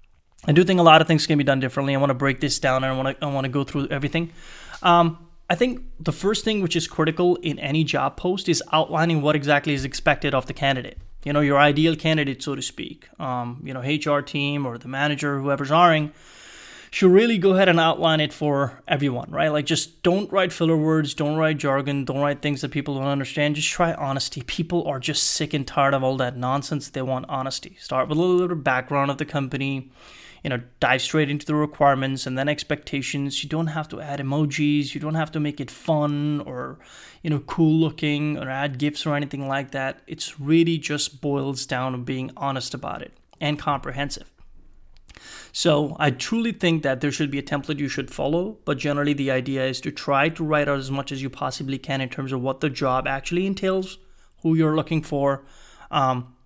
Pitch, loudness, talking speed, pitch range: 145 Hz, -23 LUFS, 220 wpm, 135-160 Hz